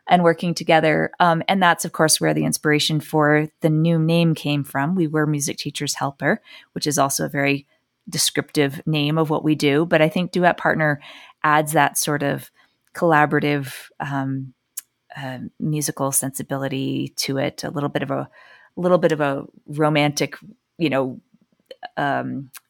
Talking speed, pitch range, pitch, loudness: 160 wpm, 140-165 Hz, 150 Hz, -20 LUFS